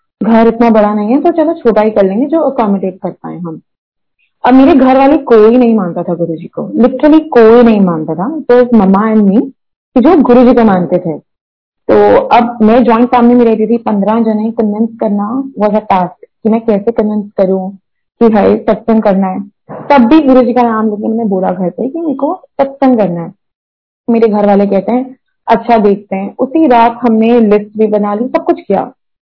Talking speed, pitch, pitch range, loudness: 205 wpm, 225 Hz, 205-250 Hz, -9 LUFS